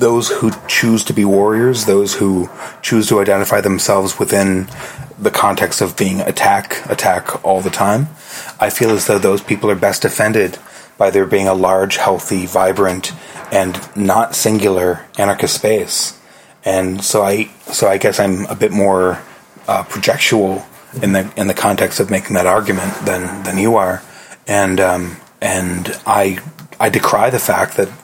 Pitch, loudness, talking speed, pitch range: 95 Hz, -14 LUFS, 165 wpm, 95-105 Hz